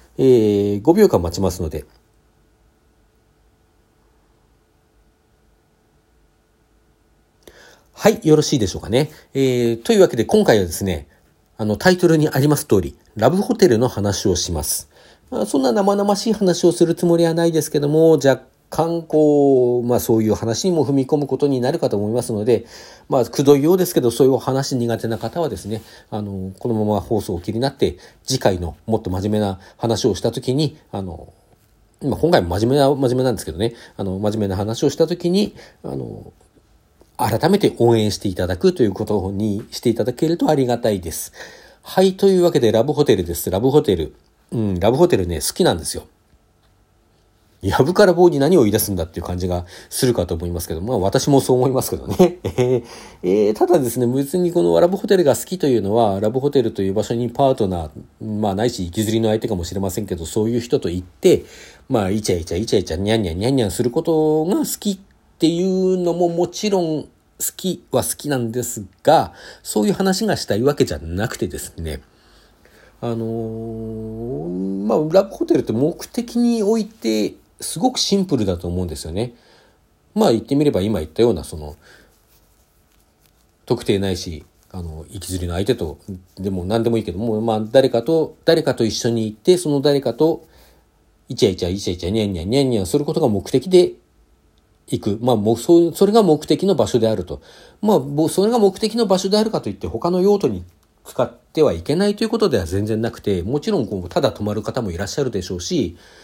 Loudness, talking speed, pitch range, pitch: -18 LUFS, 375 characters per minute, 100-155 Hz, 115 Hz